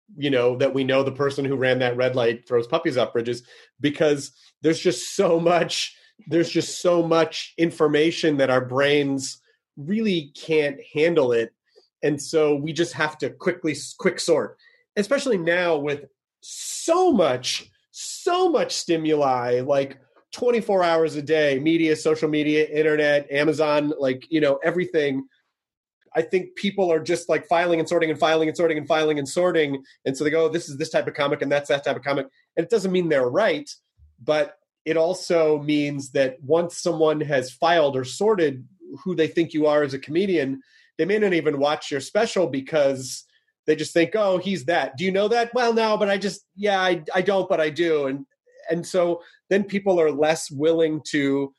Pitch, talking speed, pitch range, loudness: 160 Hz, 190 wpm, 145-180 Hz, -22 LUFS